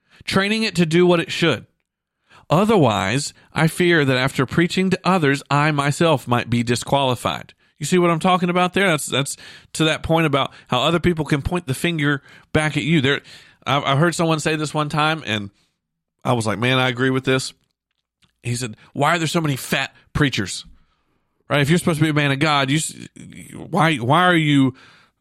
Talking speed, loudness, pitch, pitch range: 200 wpm, -19 LUFS, 150 Hz, 130-170 Hz